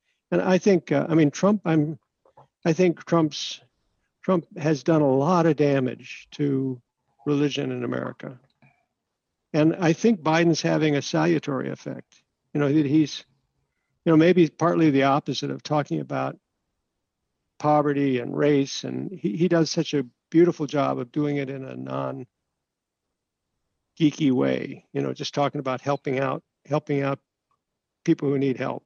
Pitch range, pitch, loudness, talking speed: 135-165 Hz, 145 Hz, -23 LUFS, 155 wpm